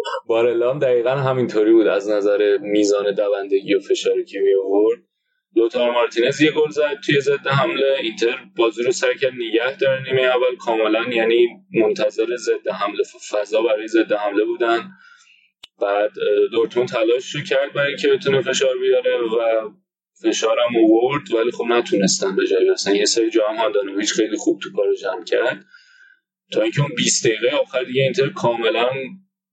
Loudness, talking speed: -19 LUFS, 155 wpm